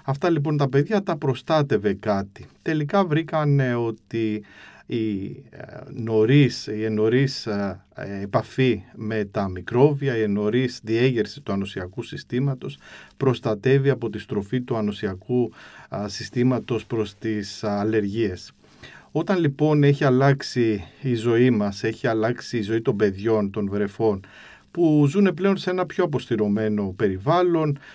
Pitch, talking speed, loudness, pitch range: 120 Hz, 120 wpm, -23 LUFS, 105-140 Hz